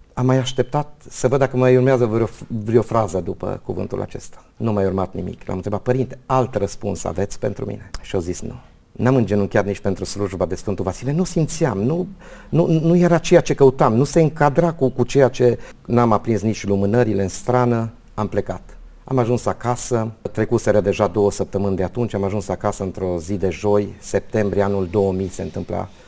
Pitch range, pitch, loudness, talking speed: 100-130 Hz, 110 Hz, -20 LUFS, 190 wpm